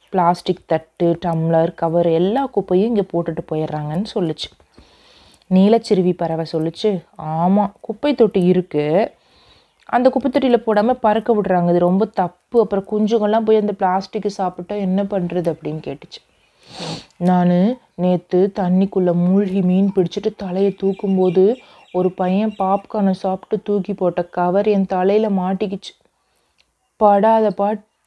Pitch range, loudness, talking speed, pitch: 175-210 Hz, -18 LUFS, 120 wpm, 190 Hz